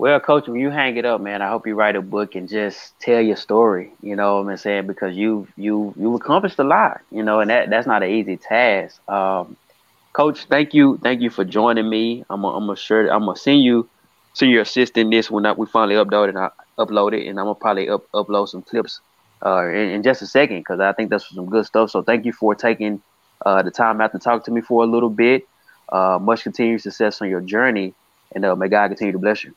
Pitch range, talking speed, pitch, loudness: 100-115 Hz, 240 wpm, 110 Hz, -18 LUFS